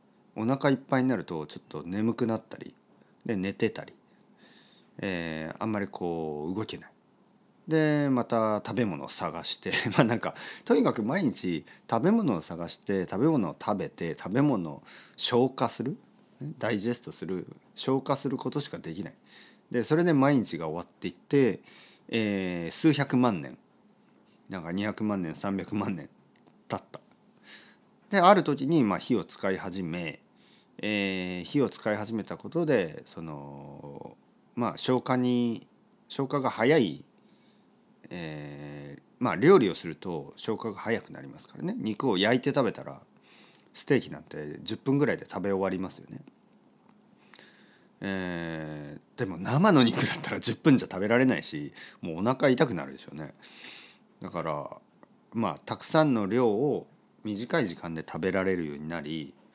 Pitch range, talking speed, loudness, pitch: 85-135 Hz, 275 characters per minute, -29 LUFS, 110 Hz